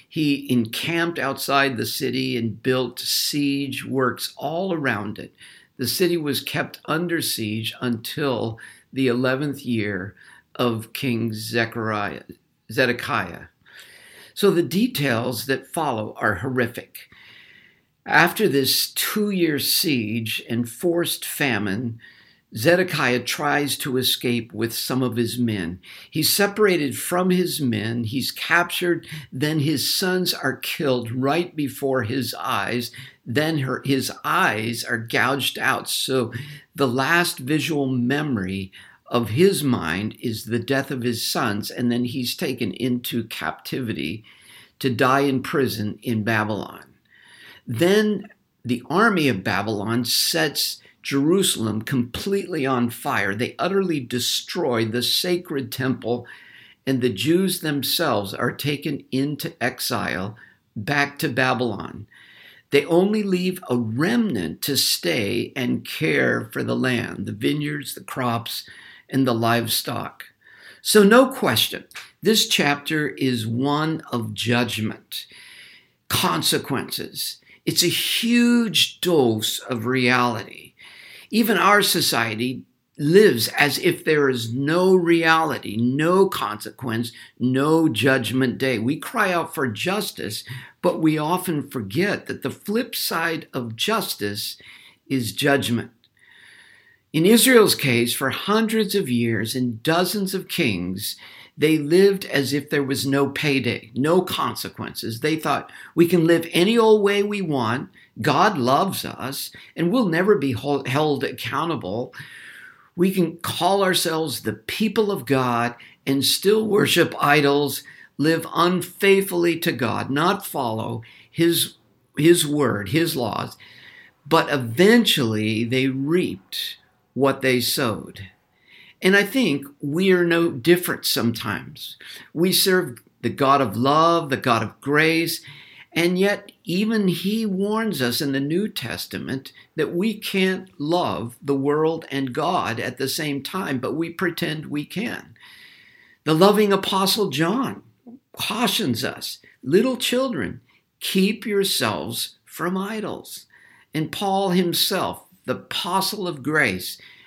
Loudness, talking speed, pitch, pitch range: -21 LUFS, 125 wpm, 140 Hz, 120-175 Hz